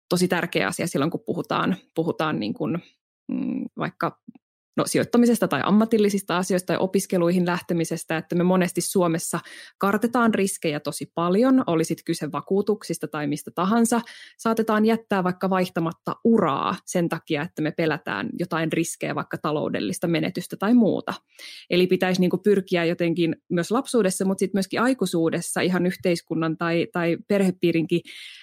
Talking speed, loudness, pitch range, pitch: 140 wpm, -23 LUFS, 165-205 Hz, 180 Hz